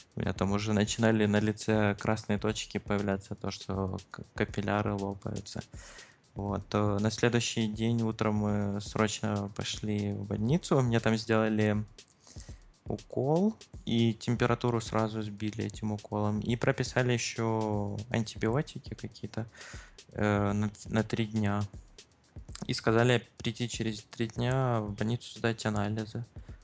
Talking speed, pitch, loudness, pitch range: 115 wpm, 110 Hz, -31 LUFS, 105-115 Hz